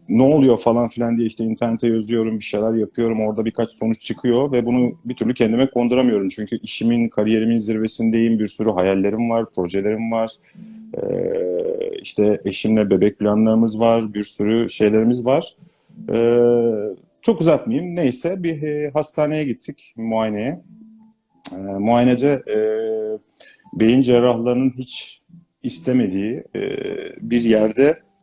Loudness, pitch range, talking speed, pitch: -19 LUFS, 110-140 Hz, 130 wpm, 115 Hz